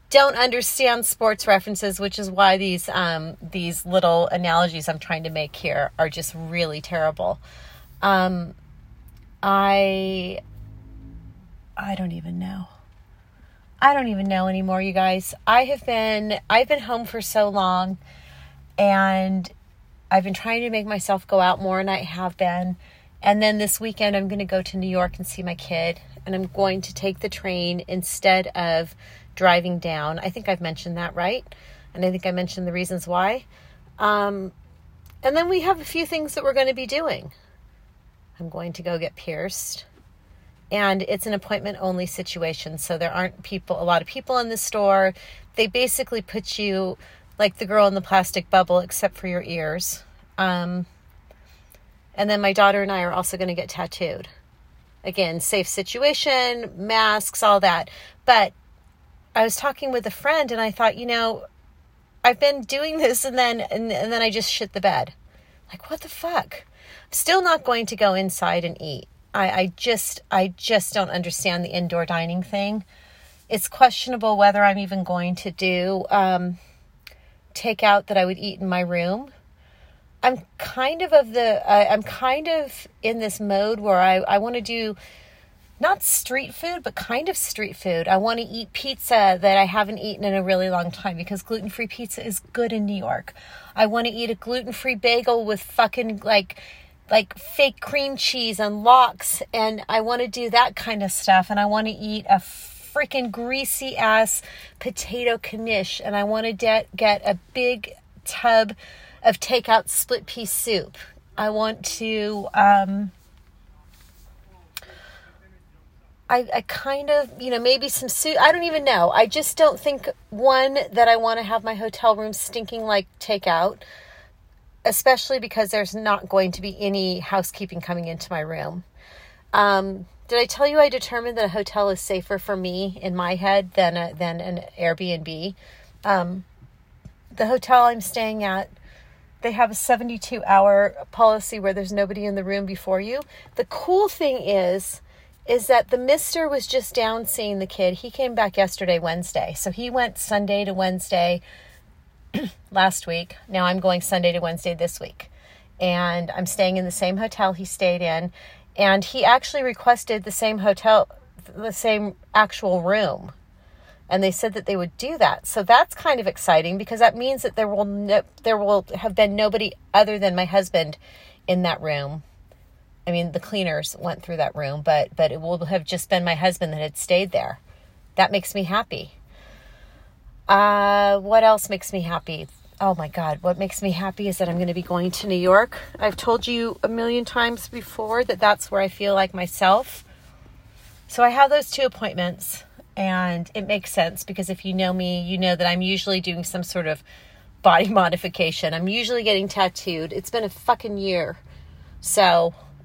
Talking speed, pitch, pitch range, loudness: 180 wpm, 195 Hz, 180-225 Hz, -21 LUFS